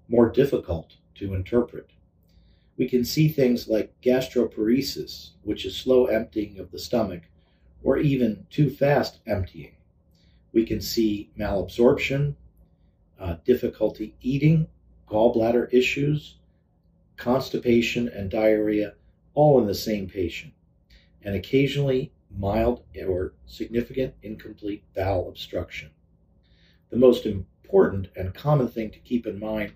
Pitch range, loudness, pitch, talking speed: 90-120 Hz, -24 LUFS, 105 Hz, 115 wpm